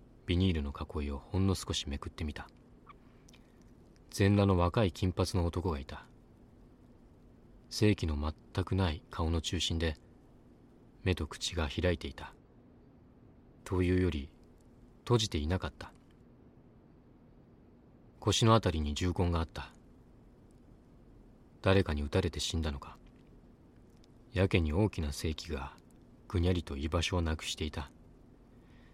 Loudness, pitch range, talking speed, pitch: -33 LUFS, 80-95 Hz, 230 characters per minute, 90 Hz